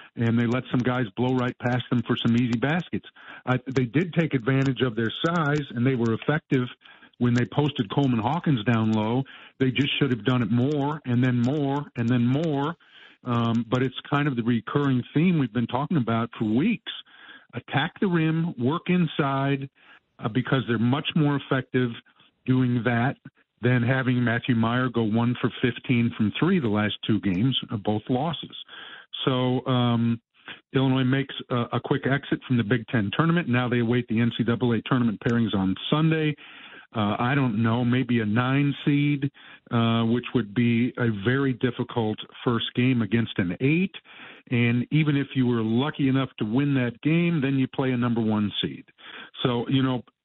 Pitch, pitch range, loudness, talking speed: 125 Hz, 120-140 Hz, -25 LUFS, 180 wpm